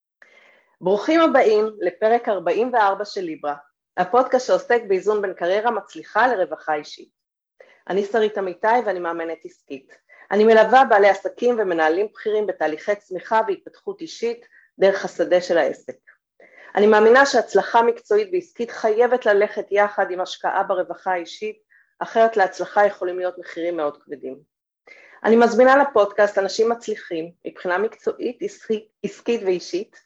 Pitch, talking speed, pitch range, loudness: 210 Hz, 125 wpm, 180-240 Hz, -20 LUFS